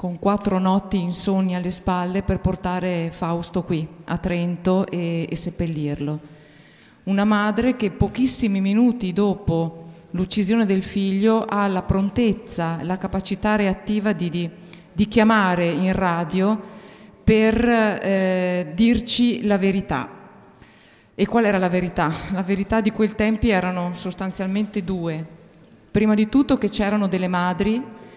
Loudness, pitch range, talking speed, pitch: -21 LUFS, 175-210 Hz, 130 wpm, 190 Hz